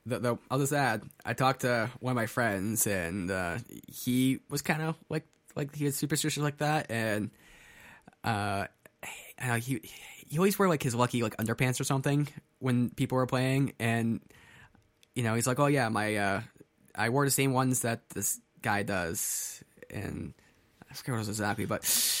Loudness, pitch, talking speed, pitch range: -30 LUFS, 125 Hz, 185 wpm, 110-140 Hz